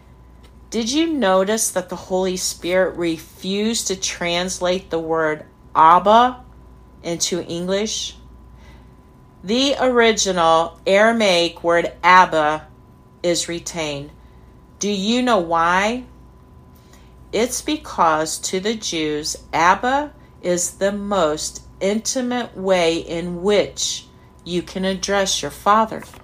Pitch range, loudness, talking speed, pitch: 155-205 Hz, -19 LUFS, 100 wpm, 180 Hz